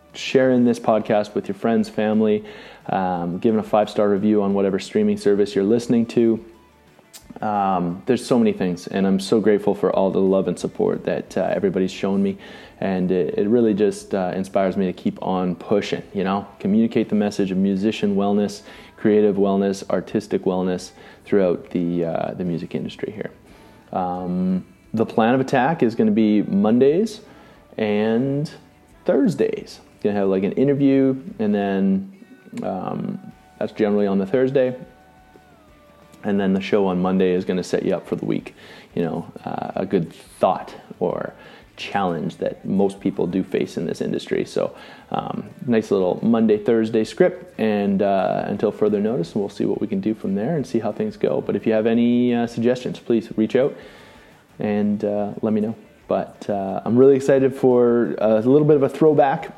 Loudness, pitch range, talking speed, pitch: -21 LUFS, 95-120 Hz, 180 wpm, 105 Hz